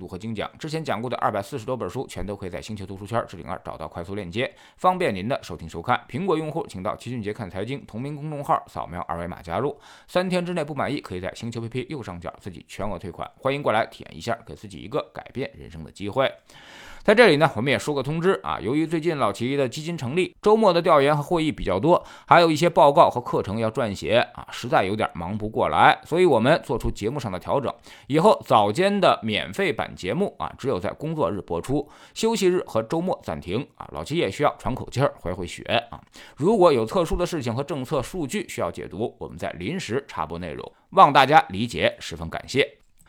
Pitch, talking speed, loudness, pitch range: 130 Hz, 350 characters per minute, -23 LUFS, 100-165 Hz